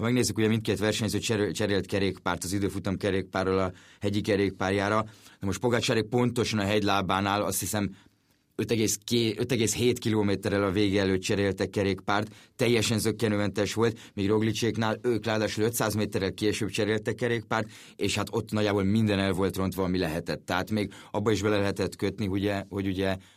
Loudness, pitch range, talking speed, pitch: -28 LUFS, 100-110 Hz, 160 wpm, 105 Hz